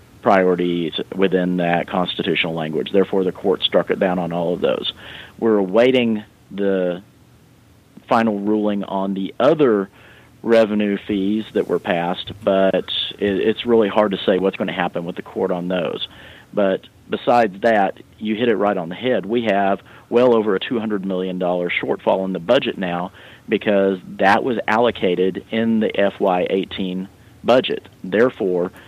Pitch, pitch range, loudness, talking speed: 100 Hz, 90-110 Hz, -19 LUFS, 155 wpm